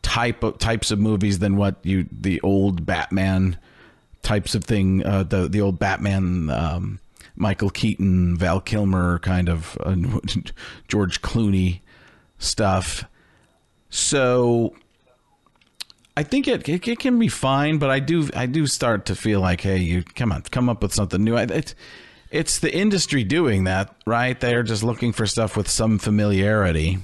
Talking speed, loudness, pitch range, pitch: 160 wpm, -21 LUFS, 95-120 Hz, 100 Hz